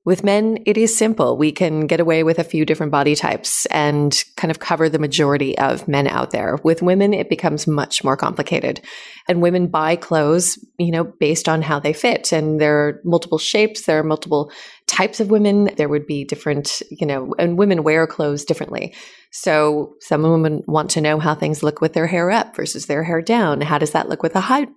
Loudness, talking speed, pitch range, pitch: -18 LUFS, 215 wpm, 150-175 Hz, 160 Hz